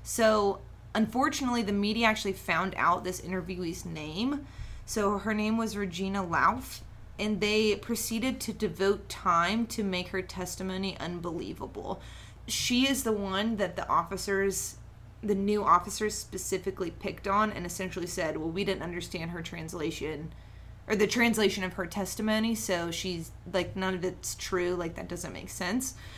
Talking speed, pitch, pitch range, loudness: 155 wpm, 195 Hz, 175-215 Hz, -30 LUFS